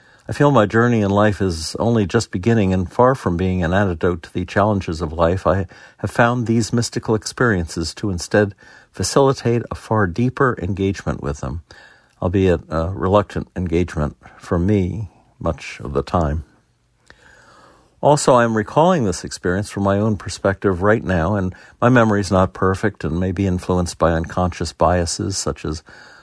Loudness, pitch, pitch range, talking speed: -19 LUFS, 95 Hz, 85-110 Hz, 165 wpm